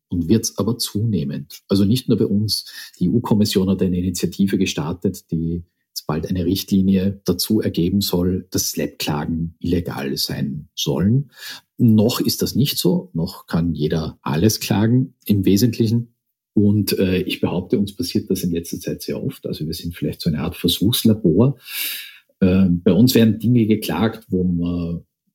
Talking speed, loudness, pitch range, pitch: 165 wpm, -19 LUFS, 90-110 Hz, 100 Hz